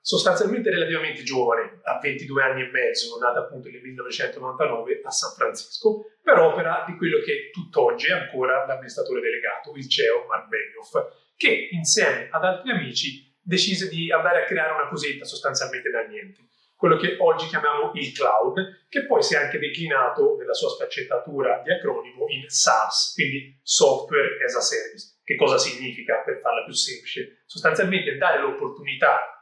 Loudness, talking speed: -23 LUFS, 160 wpm